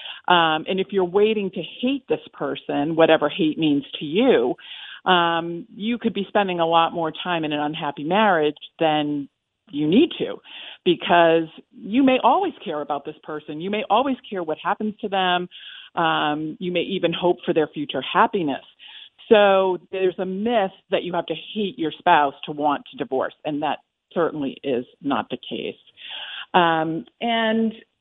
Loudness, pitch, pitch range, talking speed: -22 LUFS, 180 Hz, 155-210 Hz, 170 wpm